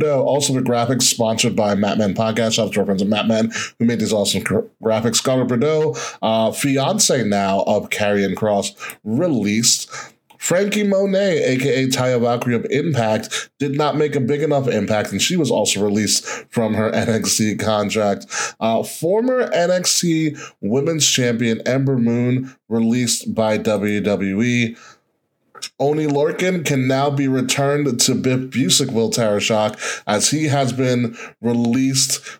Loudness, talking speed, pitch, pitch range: -18 LUFS, 145 wpm, 120 Hz, 110-140 Hz